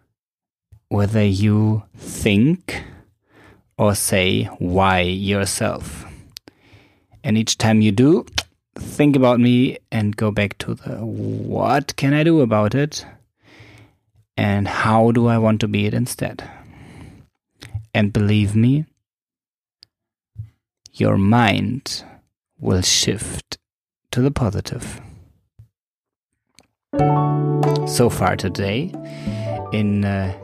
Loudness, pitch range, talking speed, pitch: -19 LUFS, 100-115 Hz, 100 wpm, 105 Hz